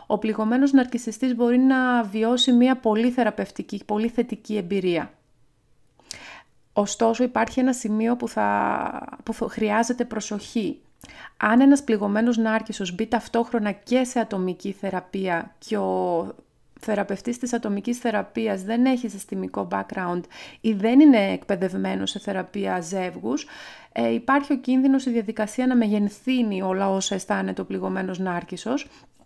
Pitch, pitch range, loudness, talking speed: 220 Hz, 195-245 Hz, -23 LUFS, 125 wpm